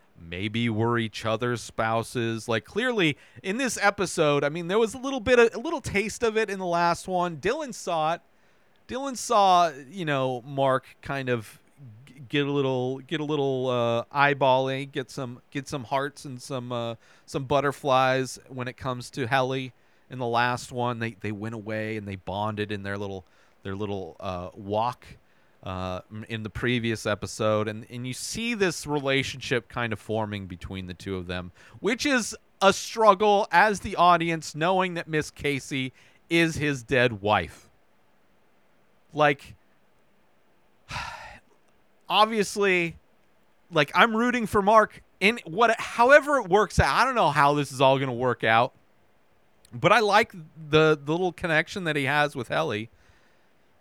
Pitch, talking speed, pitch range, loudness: 135 Hz, 165 wpm, 115-180 Hz, -25 LUFS